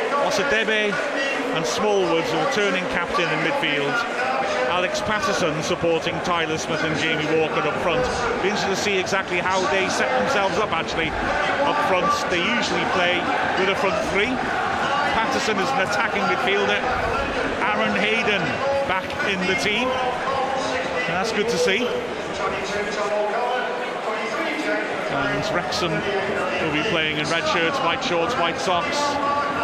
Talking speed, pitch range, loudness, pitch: 130 wpm, 180-255 Hz, -21 LUFS, 205 Hz